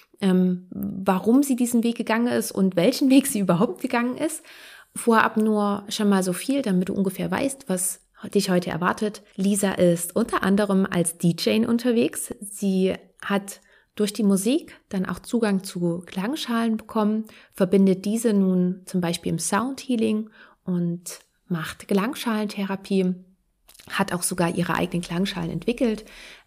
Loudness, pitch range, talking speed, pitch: -23 LUFS, 185-225 Hz, 140 wpm, 200 Hz